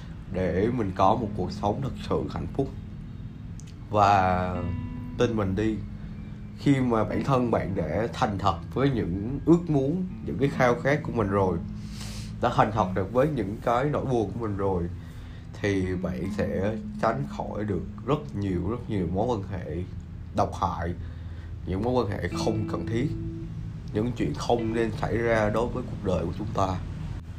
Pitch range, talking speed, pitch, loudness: 95-120 Hz, 175 wpm, 105 Hz, -27 LUFS